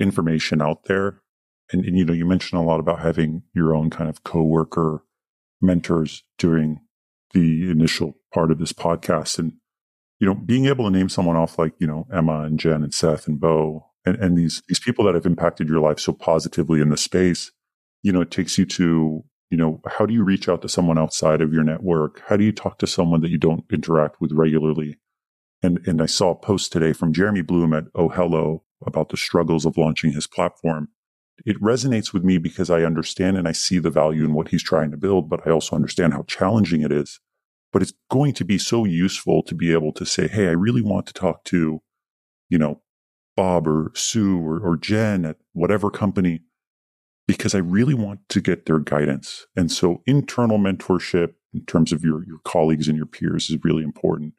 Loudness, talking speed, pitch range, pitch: -21 LUFS, 210 wpm, 80-95 Hz, 85 Hz